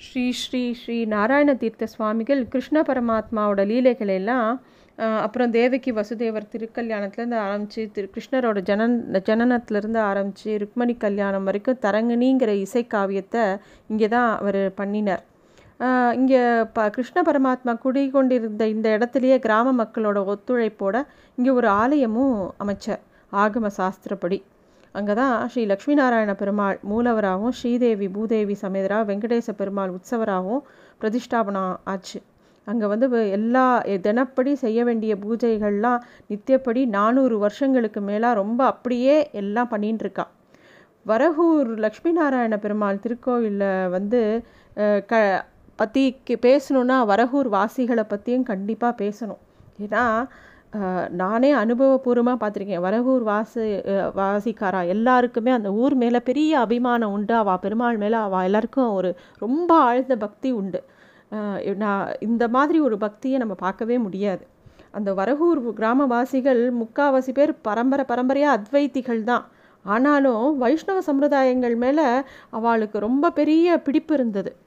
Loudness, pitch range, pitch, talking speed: -22 LUFS, 205-255 Hz, 230 Hz, 110 wpm